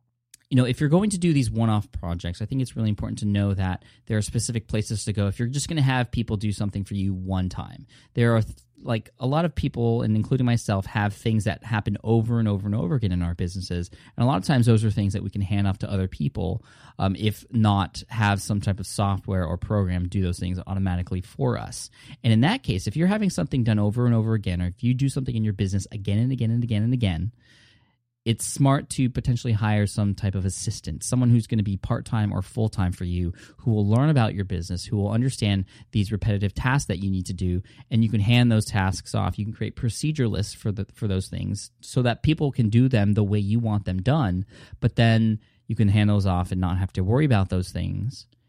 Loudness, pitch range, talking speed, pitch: -24 LUFS, 100-120 Hz, 250 wpm, 110 Hz